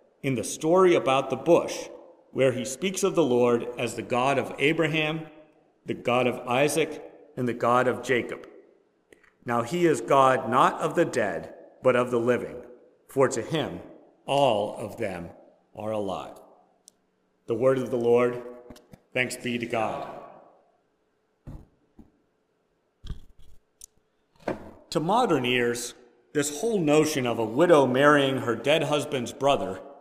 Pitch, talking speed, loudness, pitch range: 130 Hz, 140 wpm, -25 LUFS, 120-155 Hz